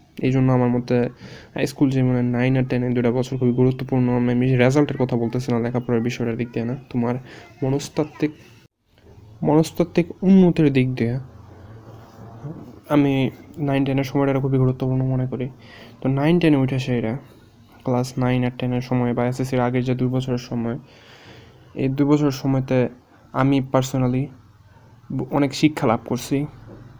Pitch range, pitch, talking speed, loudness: 120-135 Hz, 125 Hz, 140 wpm, -21 LUFS